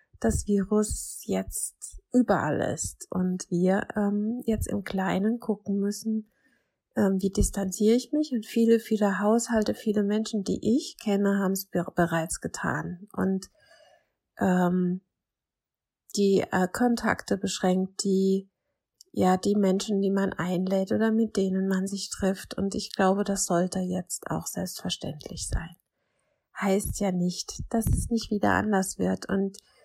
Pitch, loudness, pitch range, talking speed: 195 Hz, -27 LUFS, 185-215 Hz, 140 wpm